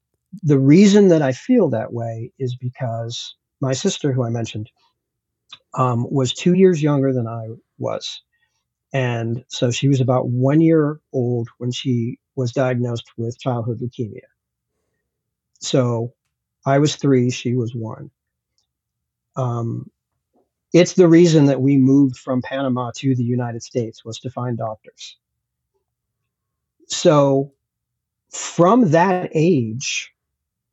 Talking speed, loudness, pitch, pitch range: 125 wpm, -18 LUFS, 130 Hz, 120-145 Hz